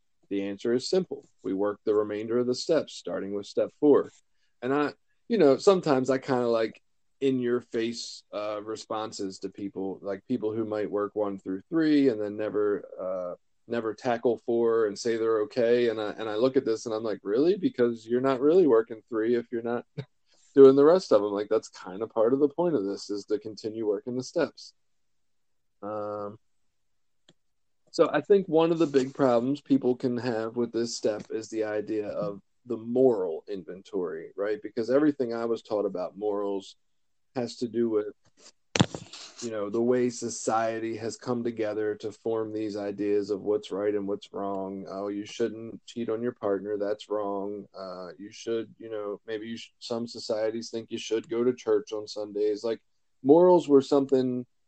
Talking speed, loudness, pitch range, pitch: 190 wpm, -28 LUFS, 105-125 Hz, 115 Hz